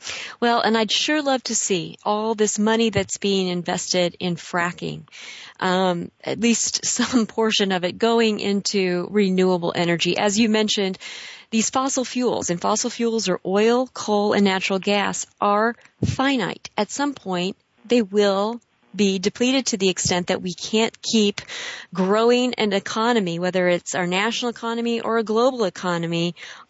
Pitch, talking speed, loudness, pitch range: 210 Hz, 155 wpm, -21 LUFS, 185-230 Hz